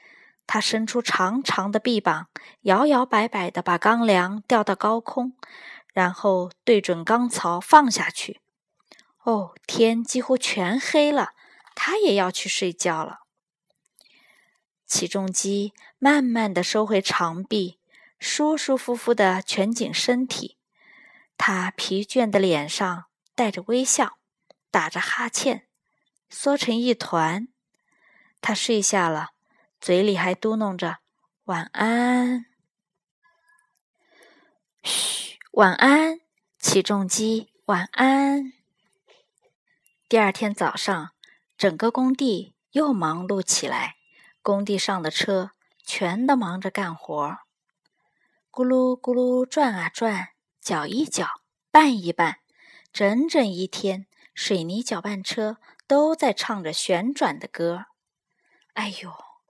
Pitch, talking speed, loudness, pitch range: 220 Hz, 160 characters per minute, -23 LUFS, 190-255 Hz